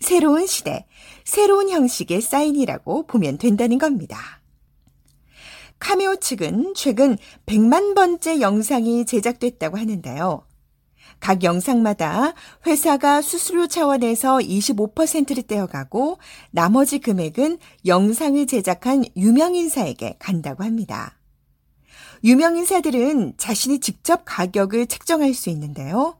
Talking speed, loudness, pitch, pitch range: 255 characters per minute, -19 LUFS, 250 Hz, 205-305 Hz